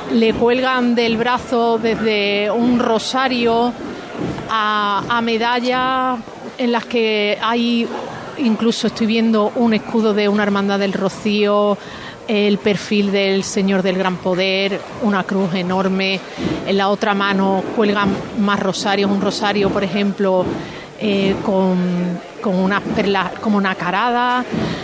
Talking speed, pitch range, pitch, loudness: 130 wpm, 195-230 Hz, 205 Hz, -17 LUFS